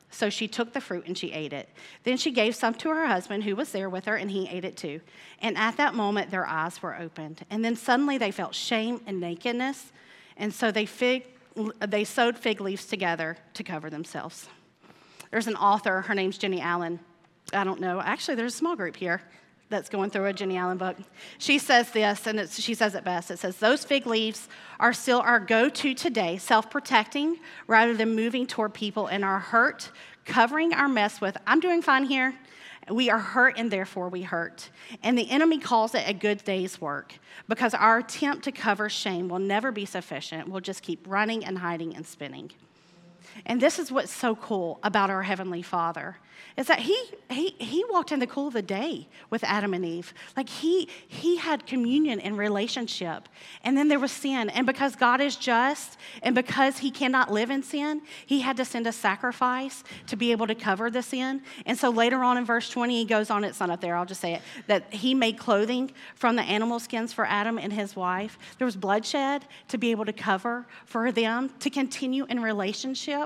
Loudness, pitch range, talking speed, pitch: -27 LUFS, 195-255 Hz, 210 wpm, 225 Hz